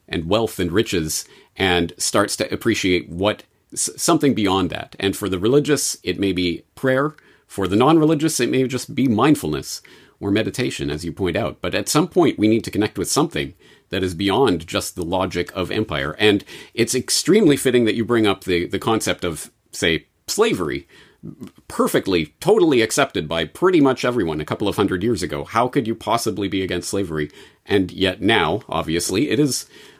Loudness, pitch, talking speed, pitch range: -20 LUFS, 100 Hz, 185 wpm, 90-115 Hz